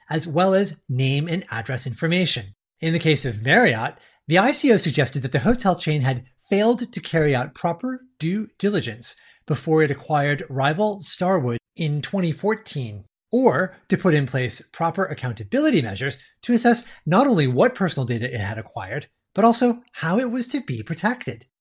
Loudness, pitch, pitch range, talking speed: -22 LUFS, 160 Hz, 130-200 Hz, 165 wpm